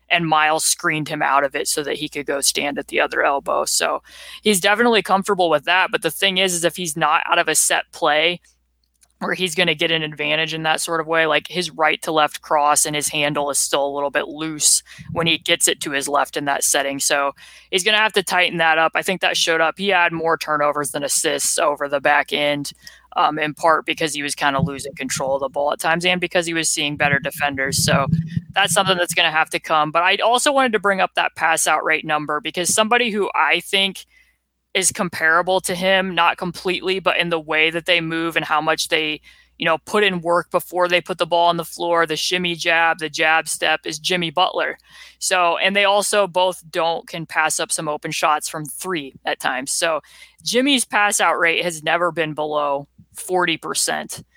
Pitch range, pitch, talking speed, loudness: 150-180 Hz, 165 Hz, 230 wpm, -18 LUFS